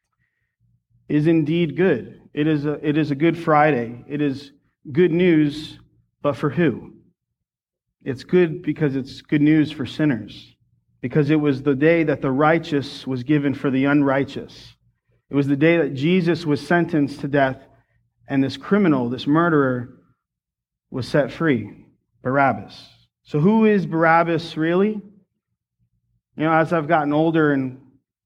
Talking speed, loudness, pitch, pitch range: 150 wpm, -20 LUFS, 145 Hz, 130-160 Hz